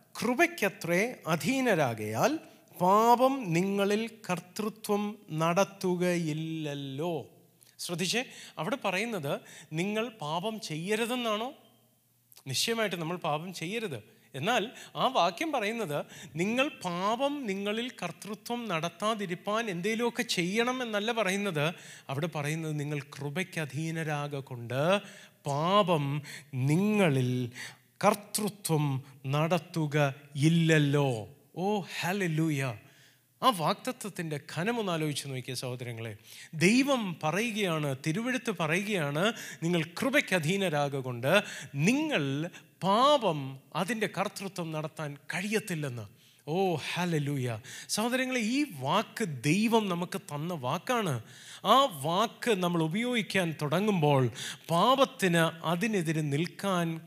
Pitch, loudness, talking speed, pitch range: 175 Hz, -30 LUFS, 80 wpm, 150-210 Hz